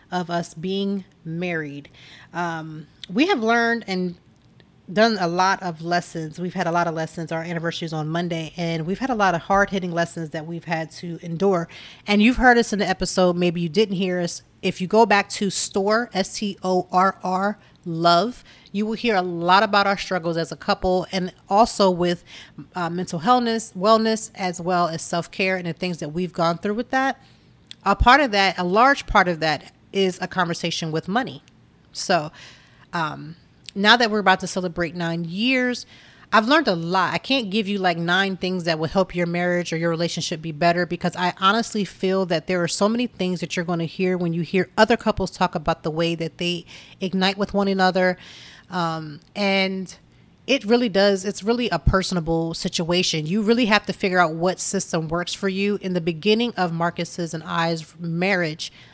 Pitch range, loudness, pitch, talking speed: 170-200 Hz, -21 LUFS, 180 Hz, 200 wpm